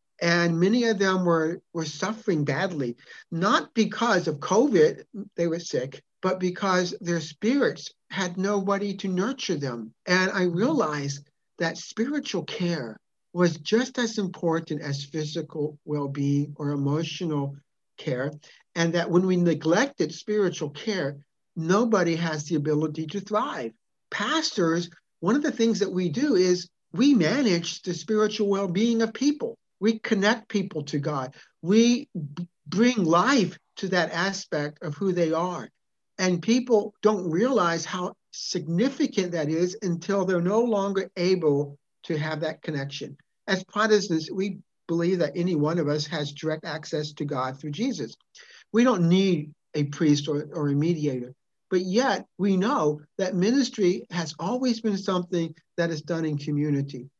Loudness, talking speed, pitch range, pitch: -26 LUFS, 150 wpm, 155-205 Hz, 175 Hz